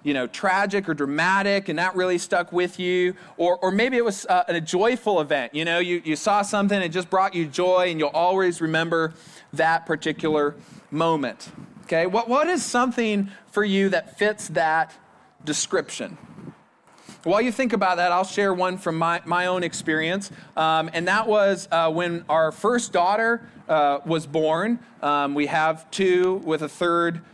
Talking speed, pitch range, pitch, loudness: 180 wpm, 160-200 Hz, 180 Hz, -23 LUFS